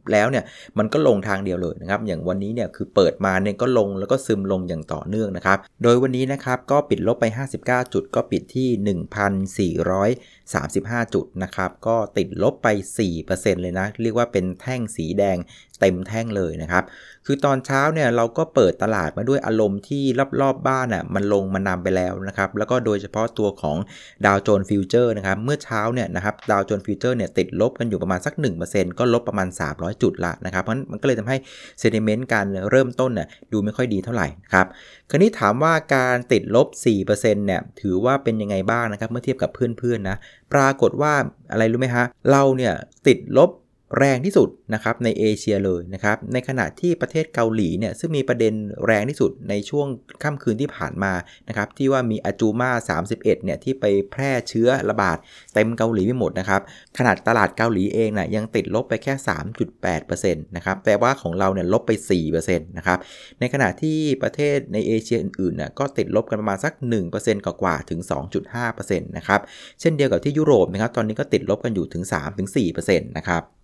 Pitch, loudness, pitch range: 110 Hz, -21 LUFS, 95-125 Hz